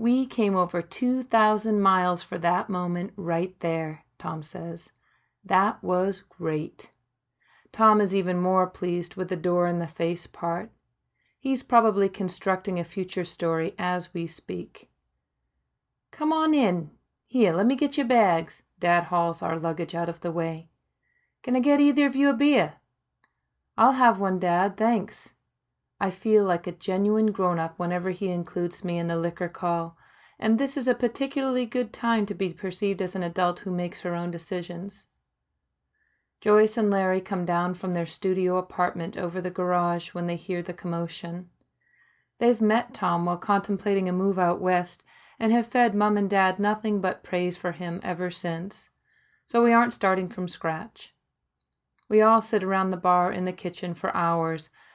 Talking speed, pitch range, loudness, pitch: 170 wpm, 170-210 Hz, -26 LUFS, 180 Hz